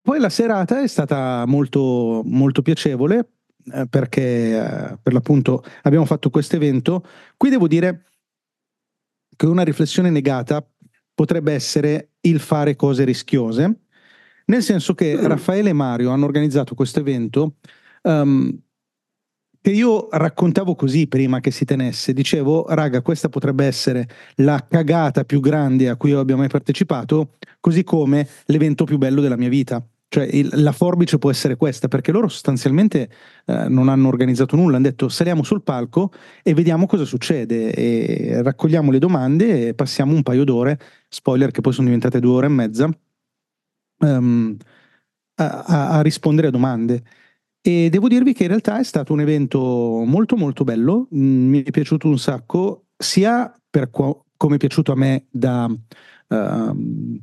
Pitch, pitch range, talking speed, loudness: 145 Hz, 130-165 Hz, 155 wpm, -18 LUFS